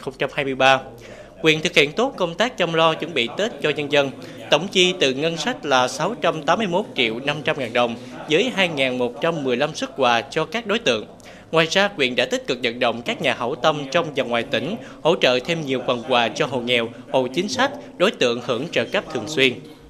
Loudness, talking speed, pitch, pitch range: -20 LUFS, 210 wpm, 145 Hz, 125-165 Hz